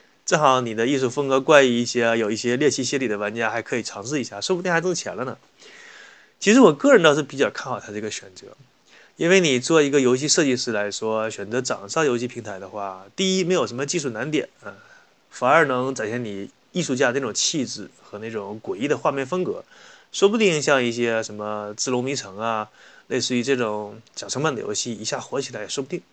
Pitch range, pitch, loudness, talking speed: 110-165 Hz, 125 Hz, -22 LUFS, 330 characters per minute